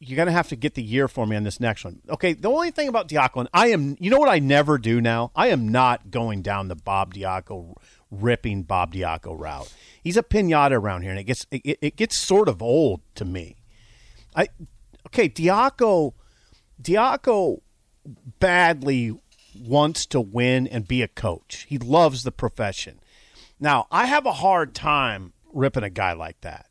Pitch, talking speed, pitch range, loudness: 125 Hz, 190 wpm, 105-150 Hz, -22 LUFS